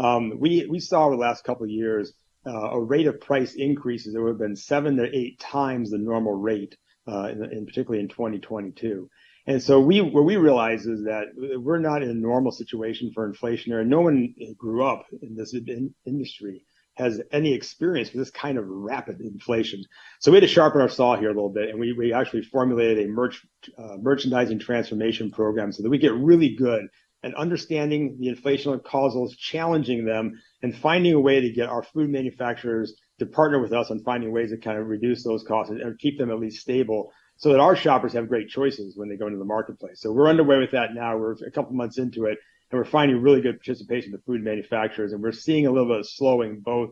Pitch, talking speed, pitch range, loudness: 120 Hz, 225 wpm, 110-140 Hz, -23 LUFS